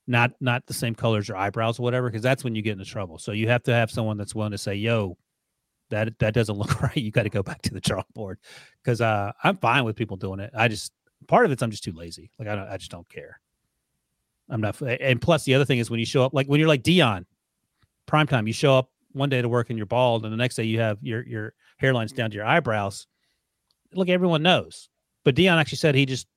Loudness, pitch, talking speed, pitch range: -24 LUFS, 115 Hz, 260 wpm, 110-130 Hz